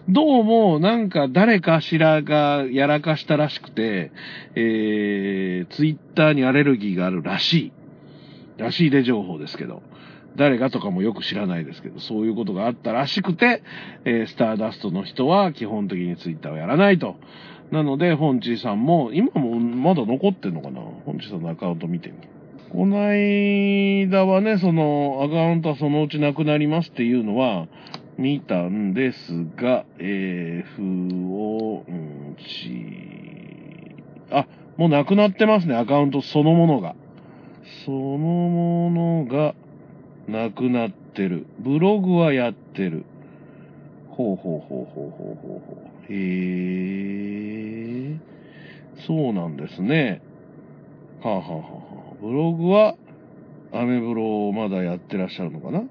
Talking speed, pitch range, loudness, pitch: 290 characters per minute, 105-165 Hz, -21 LUFS, 140 Hz